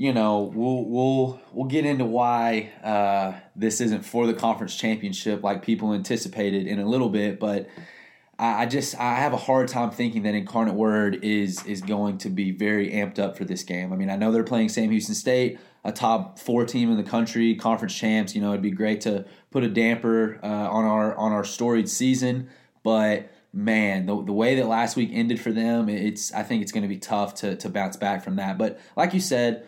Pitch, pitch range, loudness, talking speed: 110 Hz, 105-120 Hz, -24 LUFS, 220 wpm